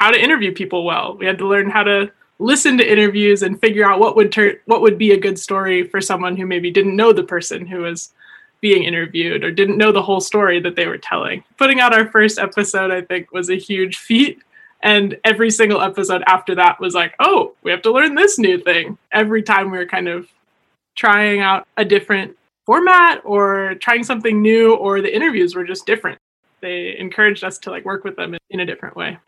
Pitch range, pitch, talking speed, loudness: 185-225 Hz, 200 Hz, 220 wpm, -15 LUFS